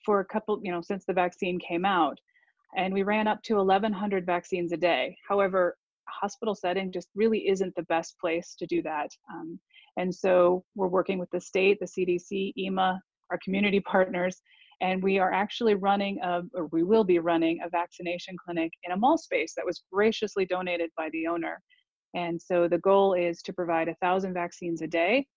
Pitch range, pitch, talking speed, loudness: 175-200 Hz, 185 Hz, 195 wpm, -28 LUFS